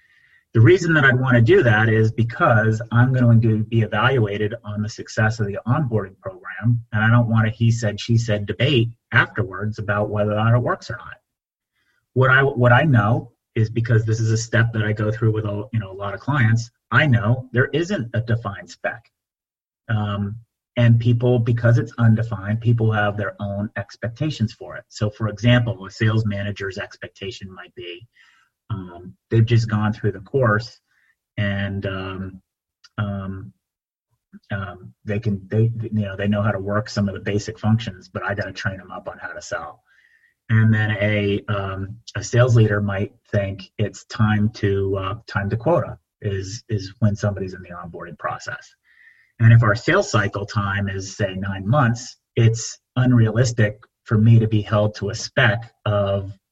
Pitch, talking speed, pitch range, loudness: 110 Hz, 185 wpm, 100-120 Hz, -20 LUFS